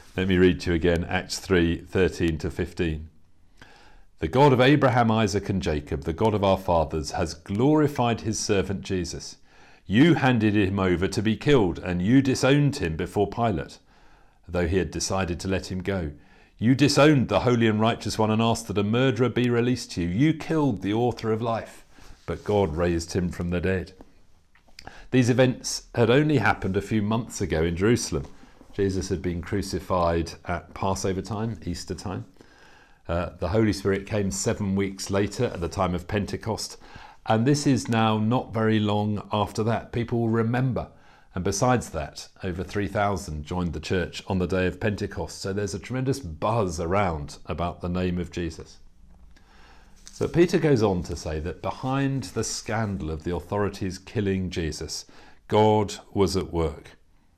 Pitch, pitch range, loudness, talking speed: 95 Hz, 90-115 Hz, -25 LUFS, 175 wpm